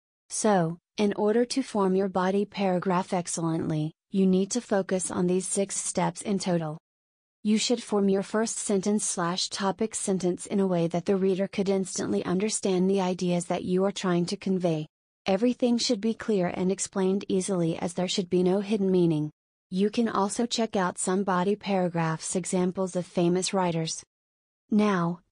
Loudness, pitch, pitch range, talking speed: -27 LUFS, 190 Hz, 180-205 Hz, 170 wpm